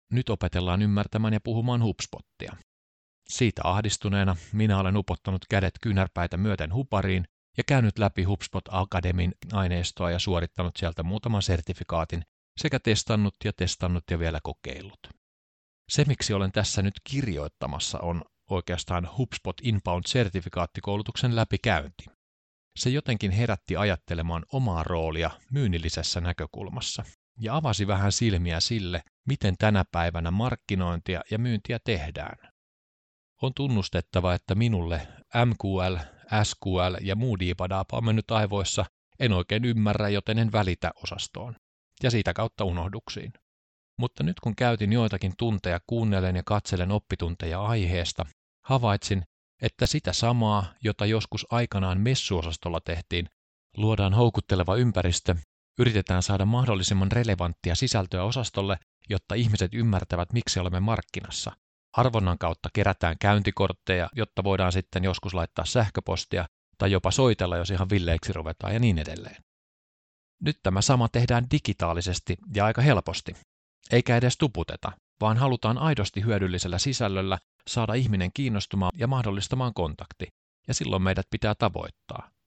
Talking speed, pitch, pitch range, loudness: 120 wpm, 95 Hz, 90-110 Hz, -27 LUFS